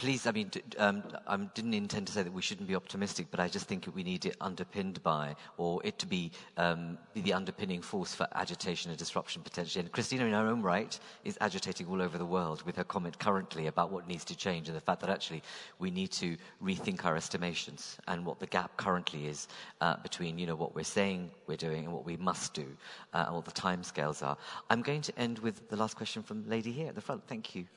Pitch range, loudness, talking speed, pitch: 85-135 Hz, -36 LUFS, 240 wpm, 95 Hz